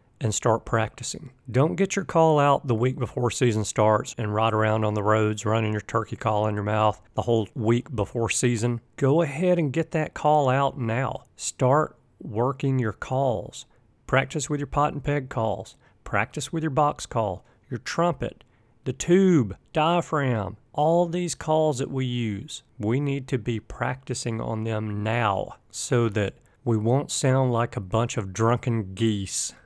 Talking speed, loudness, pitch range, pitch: 170 wpm, -25 LUFS, 110-140 Hz, 120 Hz